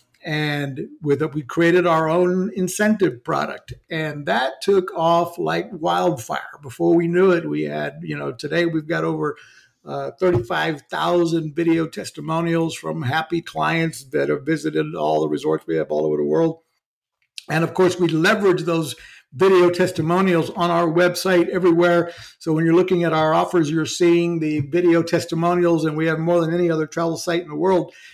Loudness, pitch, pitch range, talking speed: -20 LUFS, 165 Hz, 155-175 Hz, 175 wpm